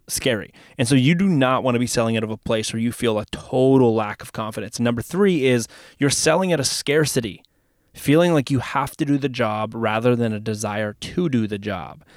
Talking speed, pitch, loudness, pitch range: 225 wpm, 120 Hz, -21 LUFS, 110-135 Hz